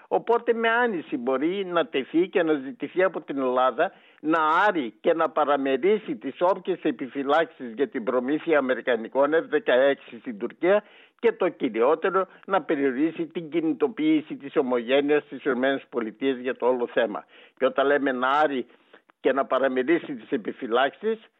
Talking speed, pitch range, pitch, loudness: 145 wpm, 135-200 Hz, 150 Hz, -25 LUFS